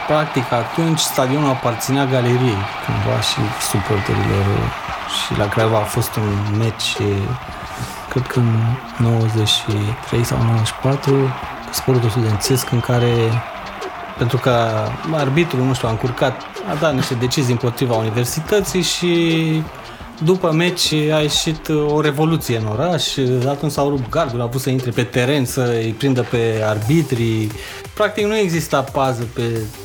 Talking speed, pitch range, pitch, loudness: 135 wpm, 115-150 Hz, 125 Hz, -18 LUFS